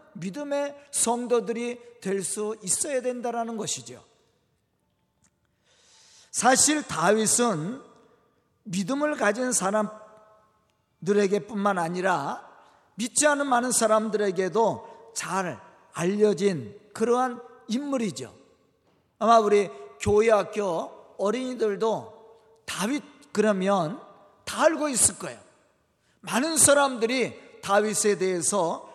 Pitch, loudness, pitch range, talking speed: 220 Hz, -25 LUFS, 200-245 Hz, 205 characters per minute